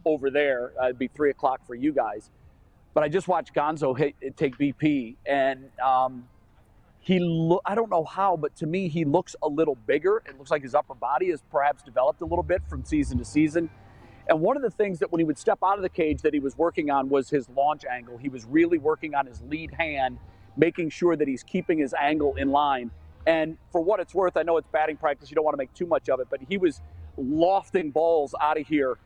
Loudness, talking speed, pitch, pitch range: -26 LUFS, 235 wpm, 155 Hz, 135-170 Hz